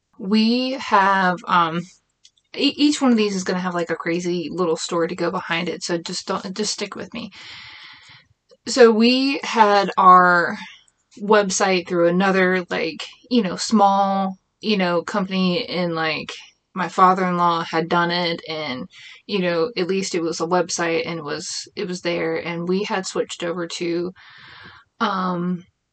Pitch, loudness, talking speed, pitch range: 185 Hz, -20 LUFS, 165 wpm, 170-205 Hz